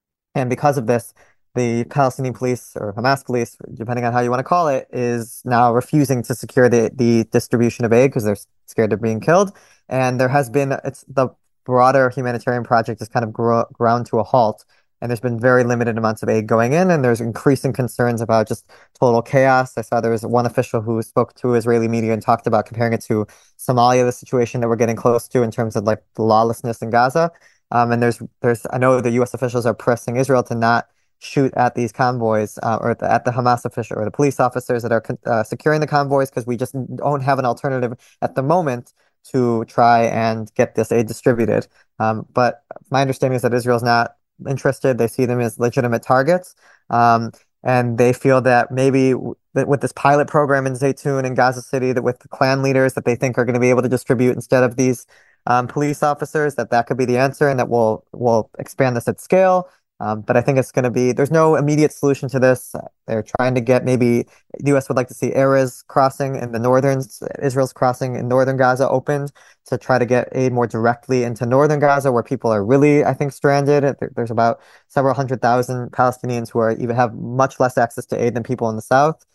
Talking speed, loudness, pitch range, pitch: 225 wpm, -18 LUFS, 120-135 Hz, 125 Hz